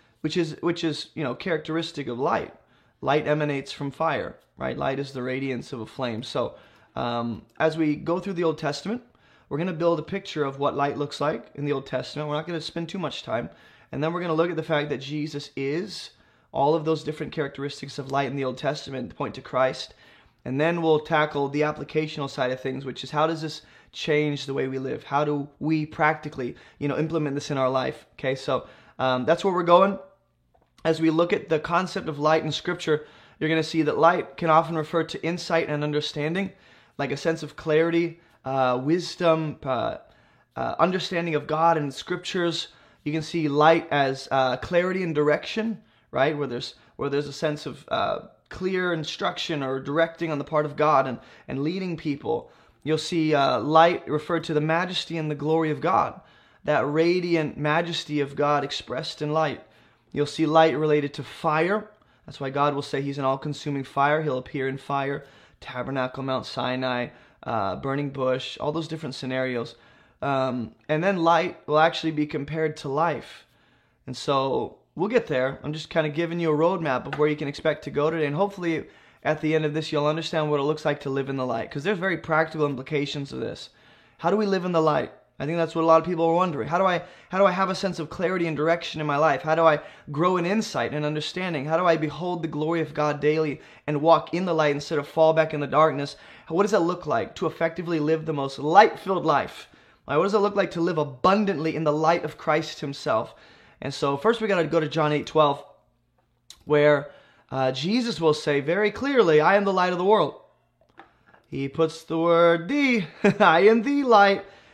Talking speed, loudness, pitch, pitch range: 215 wpm, -25 LUFS, 155 Hz, 140-165 Hz